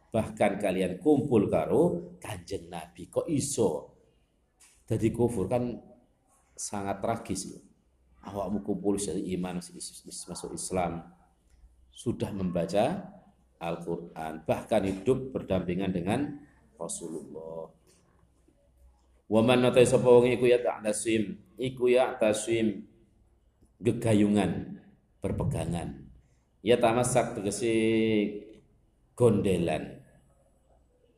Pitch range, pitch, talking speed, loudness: 85-115 Hz, 100 Hz, 75 wpm, -28 LUFS